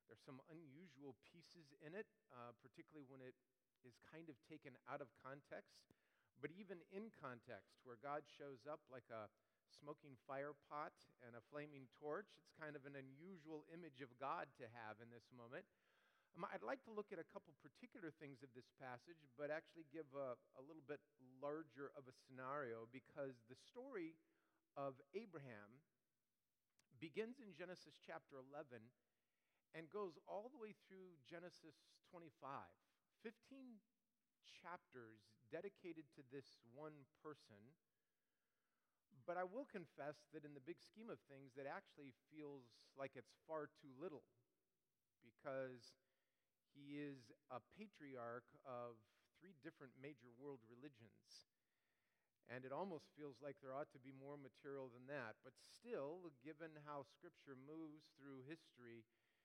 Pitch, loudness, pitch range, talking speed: 145 Hz, -57 LUFS, 130-160 Hz, 150 wpm